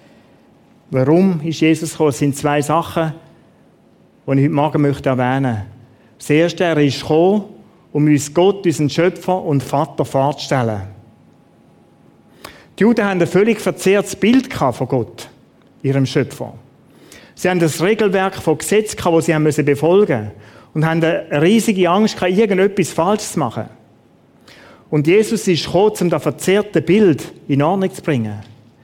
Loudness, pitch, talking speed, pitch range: -16 LUFS, 160 Hz, 150 wpm, 140-185 Hz